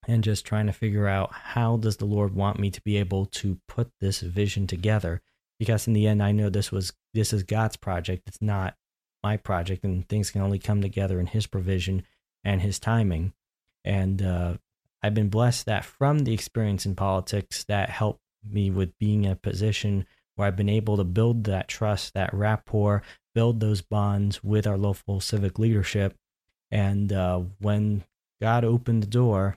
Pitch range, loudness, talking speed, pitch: 95-110 Hz, -26 LUFS, 185 wpm, 100 Hz